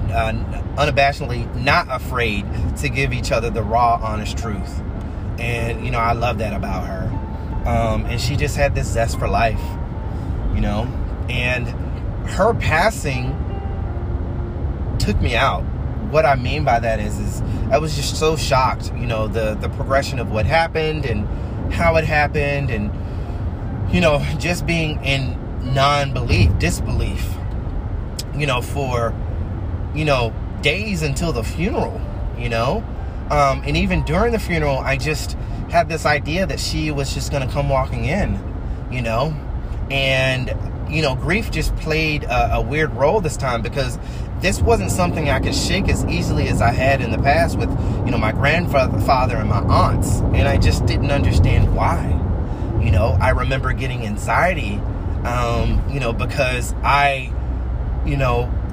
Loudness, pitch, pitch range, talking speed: -20 LUFS, 110 Hz, 95-120 Hz, 160 wpm